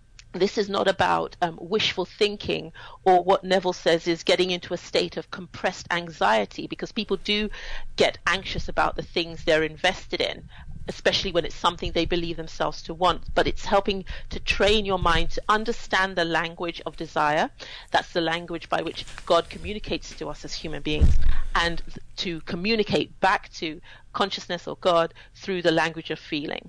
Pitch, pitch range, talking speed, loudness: 175 Hz, 165-195 Hz, 175 wpm, -25 LUFS